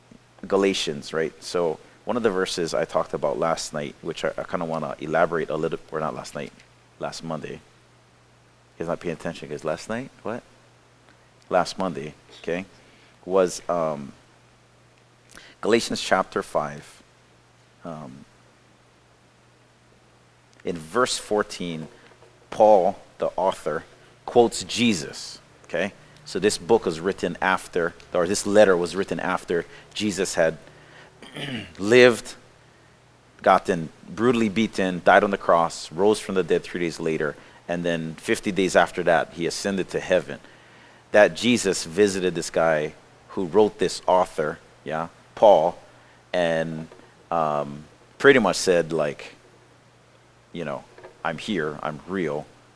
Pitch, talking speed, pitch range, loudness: 90 Hz, 130 wpm, 80-105 Hz, -23 LUFS